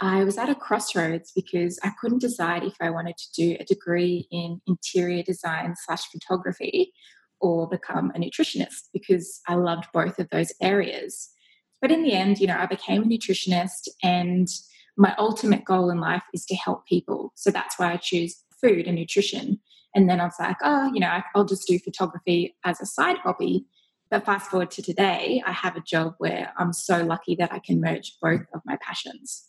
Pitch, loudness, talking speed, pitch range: 185 Hz, -25 LUFS, 195 wpm, 175-200 Hz